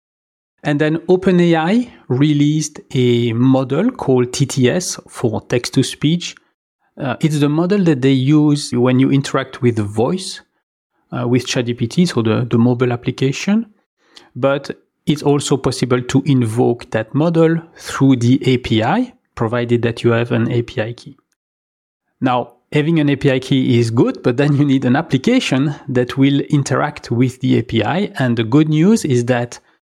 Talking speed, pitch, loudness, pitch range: 150 wpm, 135 Hz, -16 LUFS, 120-150 Hz